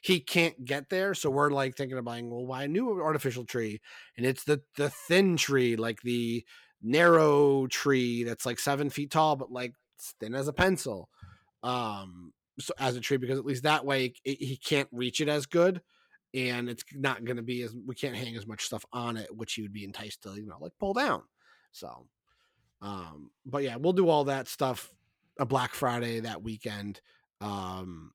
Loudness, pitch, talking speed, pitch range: -30 LUFS, 130 Hz, 205 wpm, 115-145 Hz